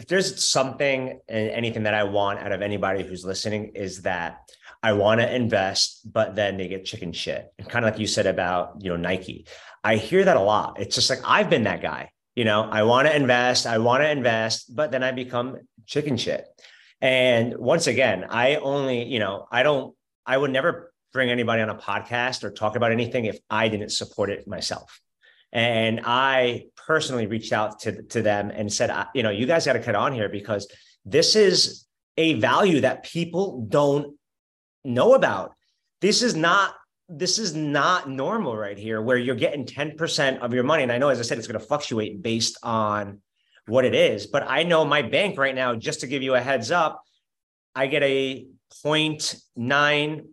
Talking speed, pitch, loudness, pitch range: 205 wpm, 120 Hz, -23 LUFS, 105-145 Hz